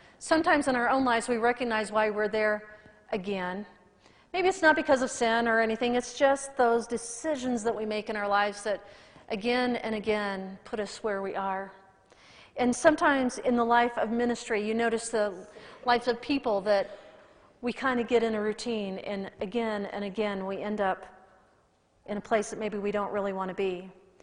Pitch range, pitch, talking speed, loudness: 205-240 Hz, 220 Hz, 190 wpm, -28 LUFS